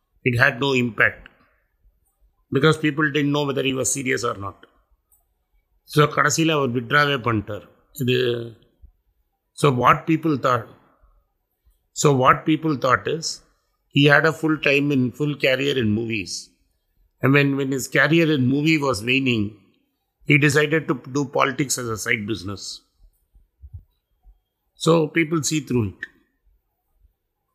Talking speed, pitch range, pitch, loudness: 120 wpm, 100-150 Hz, 130 Hz, -20 LUFS